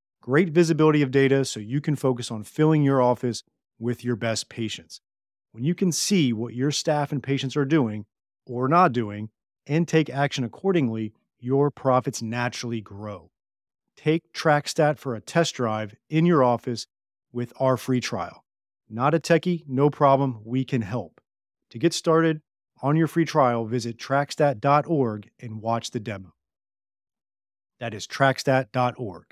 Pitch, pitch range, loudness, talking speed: 130 Hz, 115-150 Hz, -24 LUFS, 155 wpm